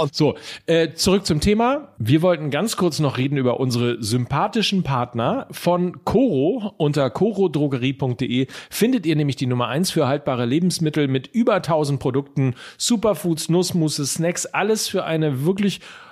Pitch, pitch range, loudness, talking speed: 155 Hz, 135-185 Hz, -21 LUFS, 145 wpm